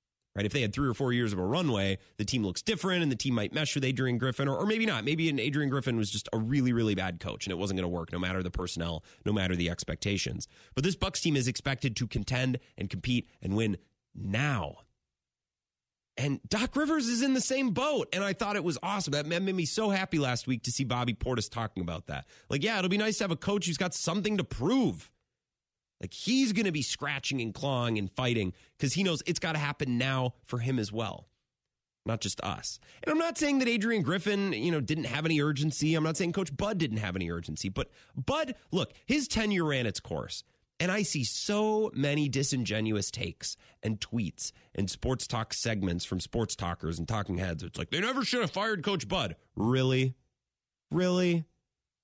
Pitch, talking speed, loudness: 130 Hz, 220 wpm, -31 LUFS